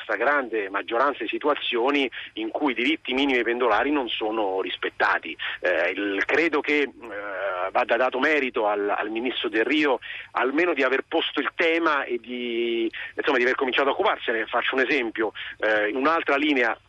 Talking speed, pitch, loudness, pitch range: 175 wpm, 135 Hz, -24 LUFS, 115-175 Hz